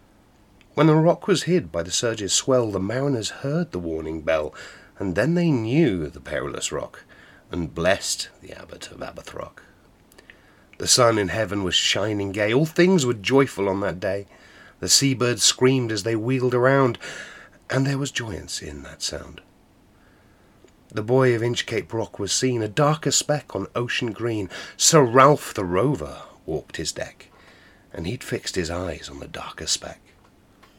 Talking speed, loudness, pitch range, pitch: 165 wpm, -22 LUFS, 95-135 Hz, 115 Hz